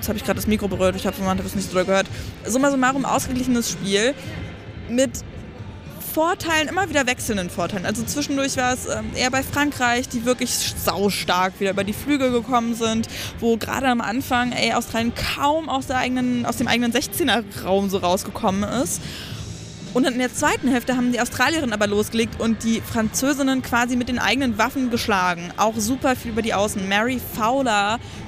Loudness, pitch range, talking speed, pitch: -21 LUFS, 210-260 Hz, 185 wpm, 240 Hz